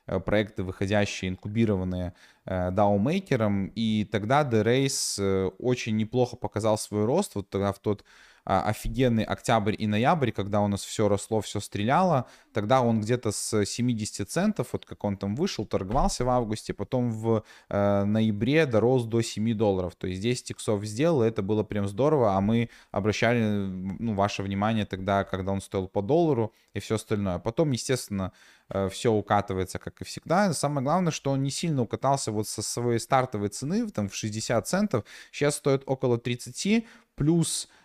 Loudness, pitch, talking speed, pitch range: -27 LUFS, 110 Hz, 165 wpm, 100-125 Hz